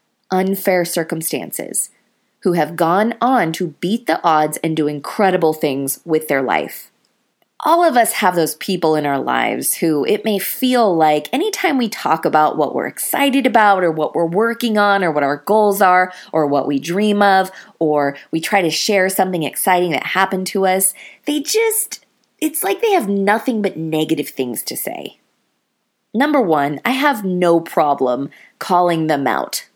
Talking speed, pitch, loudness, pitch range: 175 wpm, 185 Hz, -17 LUFS, 155-215 Hz